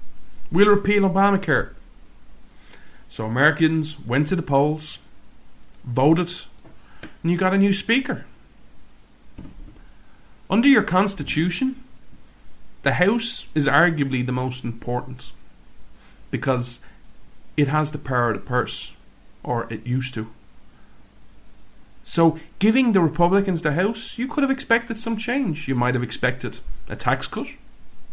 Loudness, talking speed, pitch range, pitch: -22 LUFS, 120 wpm, 125-200 Hz, 155 Hz